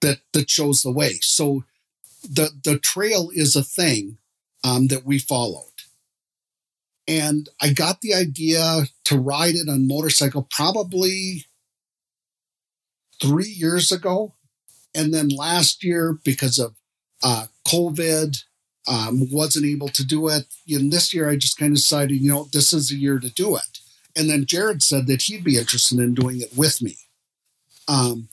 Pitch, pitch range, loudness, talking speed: 145 Hz, 135-160 Hz, -19 LUFS, 160 wpm